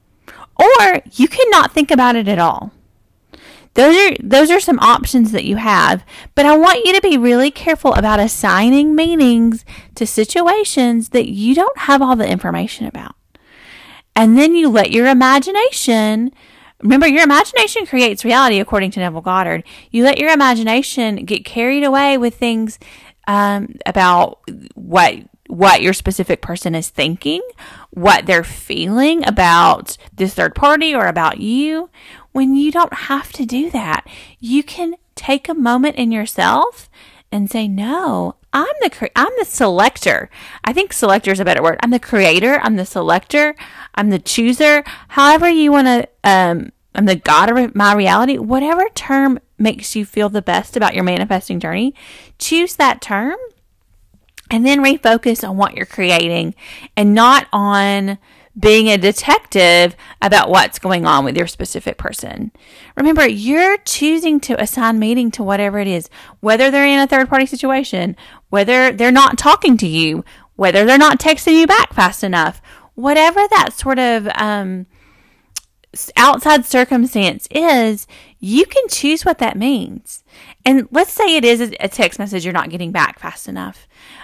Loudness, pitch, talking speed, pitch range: -13 LUFS, 245 Hz, 160 wpm, 205-290 Hz